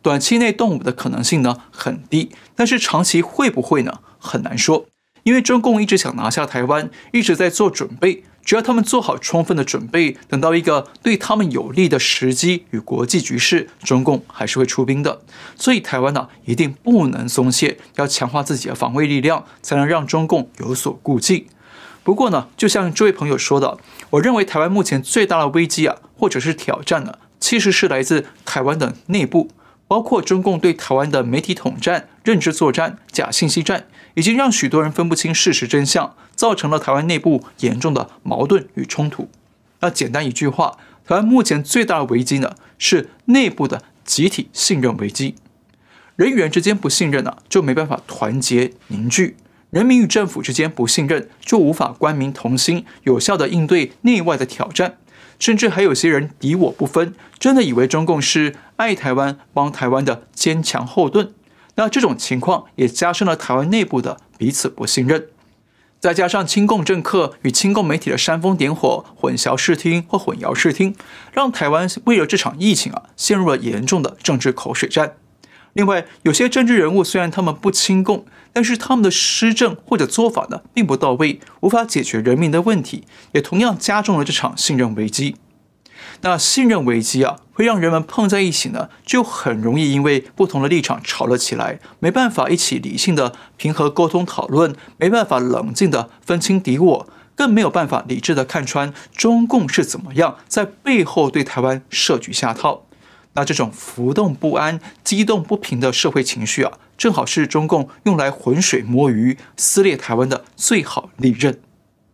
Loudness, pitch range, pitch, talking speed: -17 LUFS, 135-200 Hz, 160 Hz, 285 characters per minute